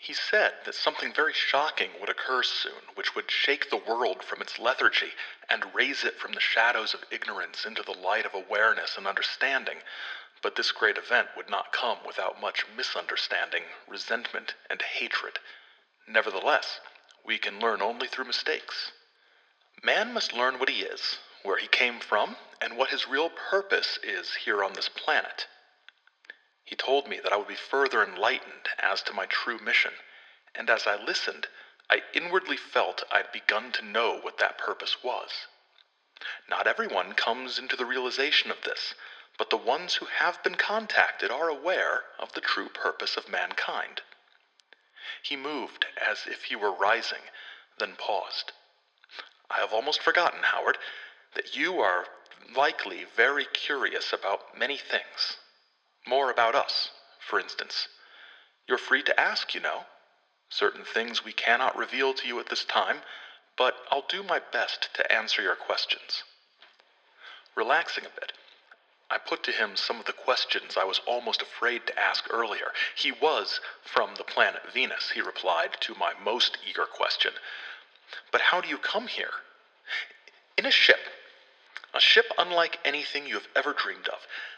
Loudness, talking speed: -28 LUFS, 160 wpm